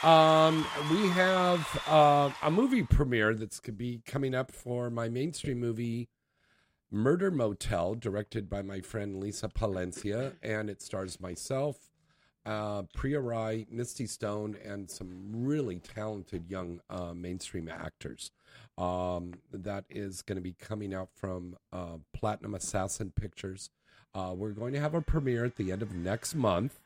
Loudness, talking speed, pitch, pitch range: -32 LUFS, 150 wpm, 110 Hz, 95-130 Hz